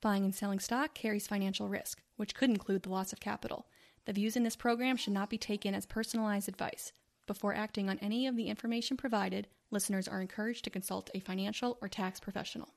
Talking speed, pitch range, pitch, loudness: 205 wpm, 200-230 Hz, 210 Hz, -36 LUFS